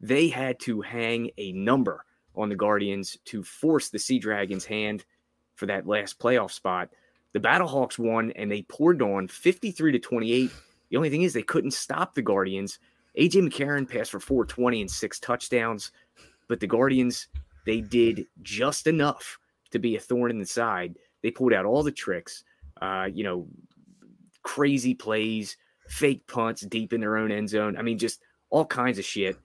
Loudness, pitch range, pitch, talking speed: -27 LUFS, 105-125 Hz, 115 Hz, 175 wpm